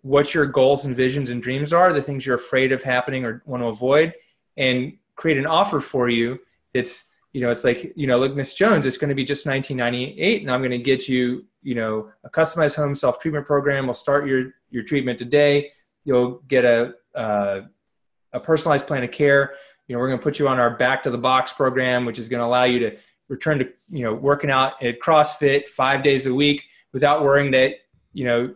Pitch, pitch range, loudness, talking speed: 130 Hz, 125-145 Hz, -20 LUFS, 225 wpm